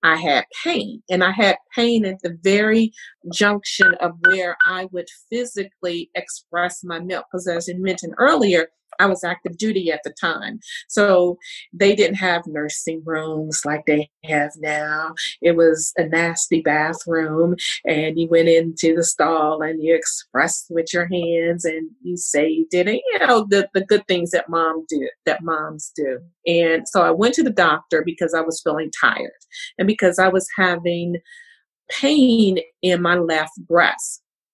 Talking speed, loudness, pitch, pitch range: 165 wpm, -19 LUFS, 175 Hz, 165-200 Hz